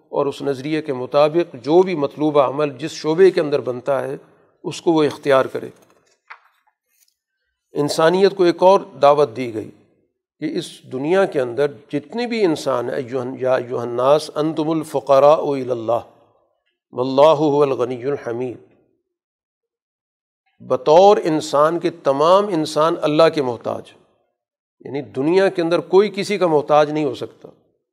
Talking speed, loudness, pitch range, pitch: 130 wpm, -18 LUFS, 140-175 Hz, 150 Hz